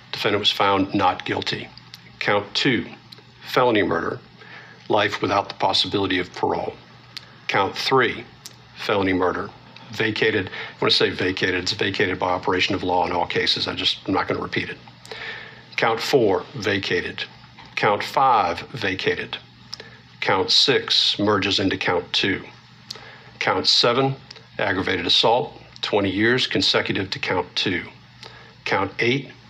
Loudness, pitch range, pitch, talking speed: -21 LUFS, 95-120 Hz, 100 Hz, 135 wpm